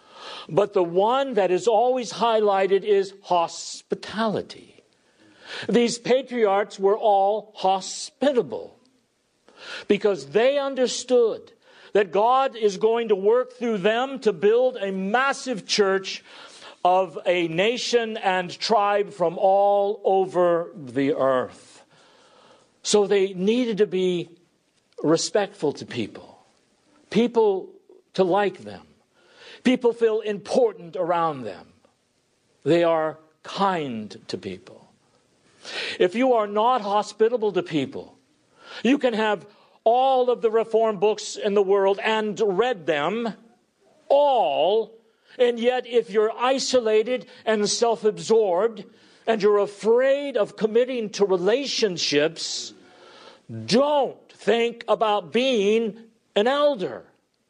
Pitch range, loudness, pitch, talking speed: 195-250 Hz, -22 LUFS, 220 Hz, 110 wpm